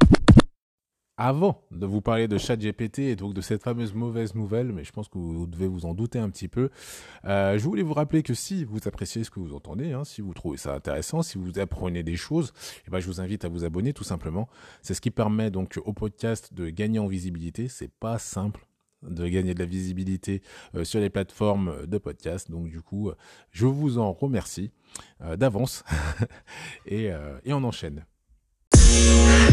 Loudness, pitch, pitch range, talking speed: -26 LUFS, 100 Hz, 90-115 Hz, 200 wpm